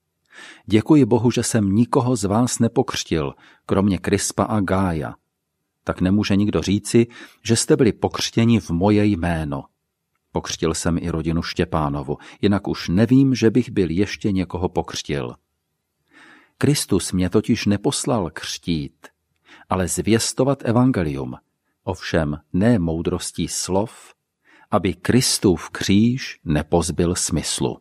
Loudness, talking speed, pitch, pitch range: -20 LUFS, 115 wpm, 100 Hz, 85-115 Hz